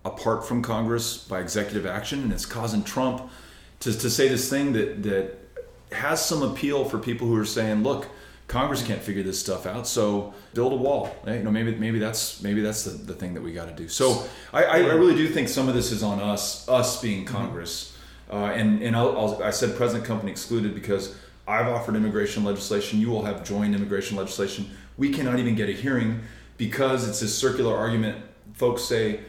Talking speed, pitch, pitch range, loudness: 210 wpm, 110 Hz, 100-120 Hz, -25 LUFS